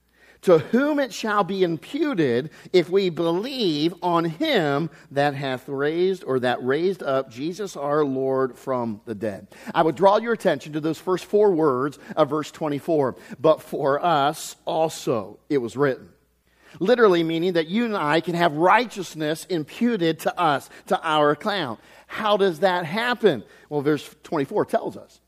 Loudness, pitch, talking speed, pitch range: -23 LUFS, 165 Hz, 160 wpm, 145-195 Hz